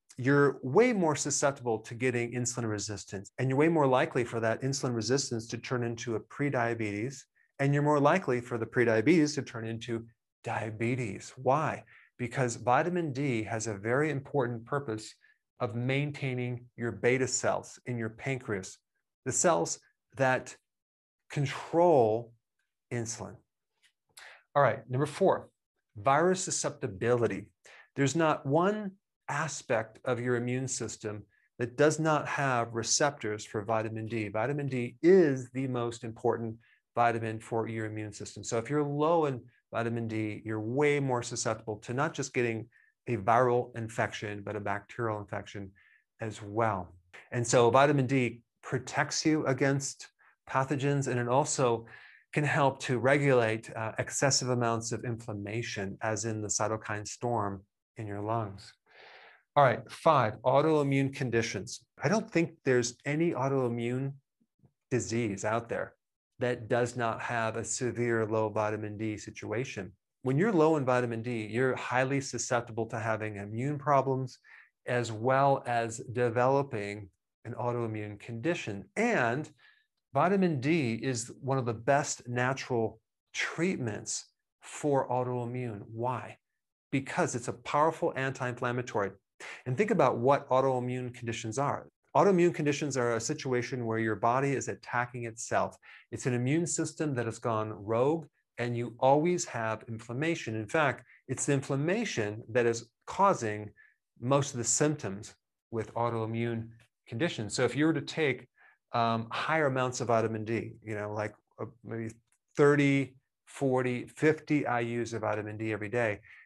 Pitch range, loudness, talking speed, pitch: 115-140 Hz, -31 LUFS, 140 wpm, 120 Hz